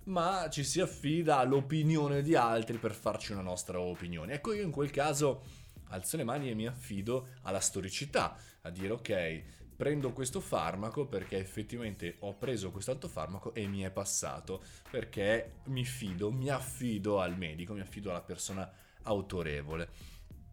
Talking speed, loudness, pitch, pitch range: 155 wpm, -35 LUFS, 105 Hz, 95-130 Hz